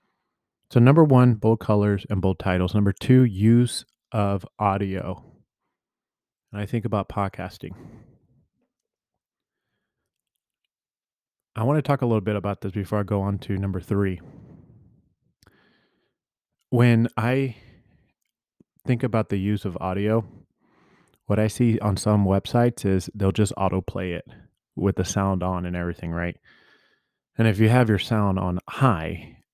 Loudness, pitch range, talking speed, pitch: -23 LUFS, 95-115 Hz, 140 wpm, 105 Hz